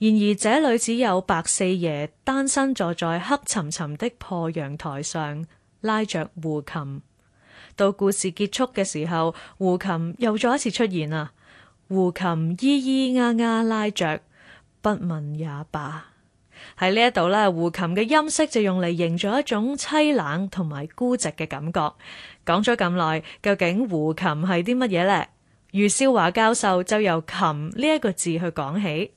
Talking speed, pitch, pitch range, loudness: 220 characters per minute, 185 Hz, 160-220 Hz, -23 LUFS